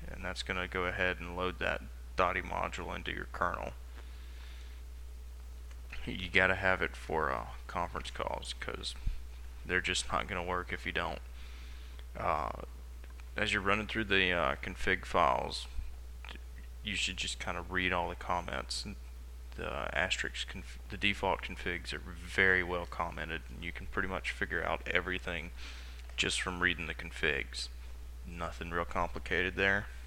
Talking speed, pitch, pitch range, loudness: 155 wpm, 70 Hz, 60-90 Hz, -34 LUFS